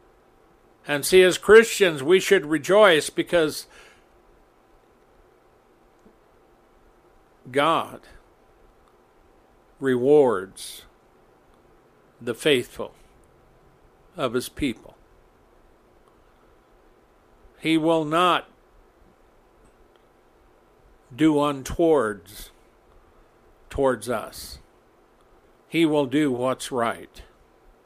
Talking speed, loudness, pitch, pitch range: 60 wpm, -21 LUFS, 155 Hz, 130-180 Hz